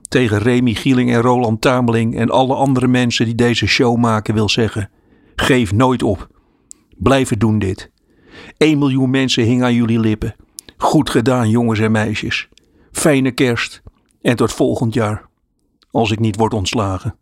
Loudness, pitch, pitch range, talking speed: -15 LUFS, 120 Hz, 110-125 Hz, 155 wpm